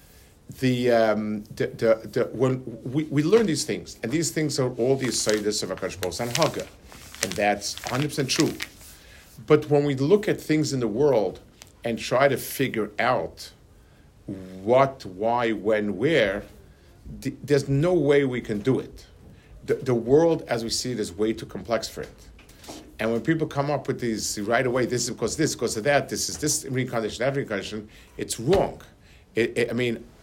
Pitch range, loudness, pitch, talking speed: 105-140 Hz, -24 LUFS, 120 Hz, 185 wpm